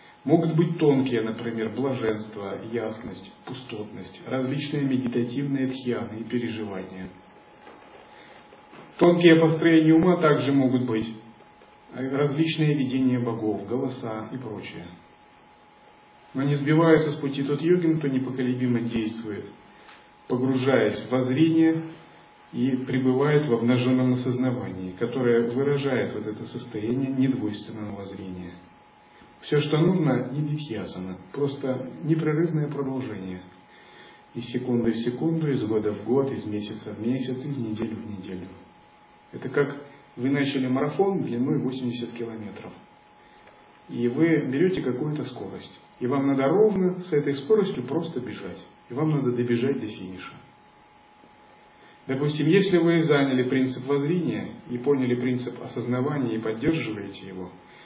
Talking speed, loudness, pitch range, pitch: 120 wpm, -25 LUFS, 115-145 Hz, 130 Hz